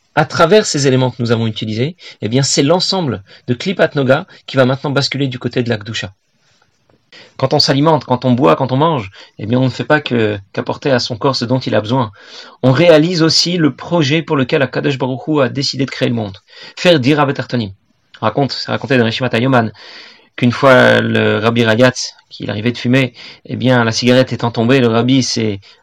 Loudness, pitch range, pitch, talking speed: -14 LUFS, 120-145 Hz, 130 Hz, 210 wpm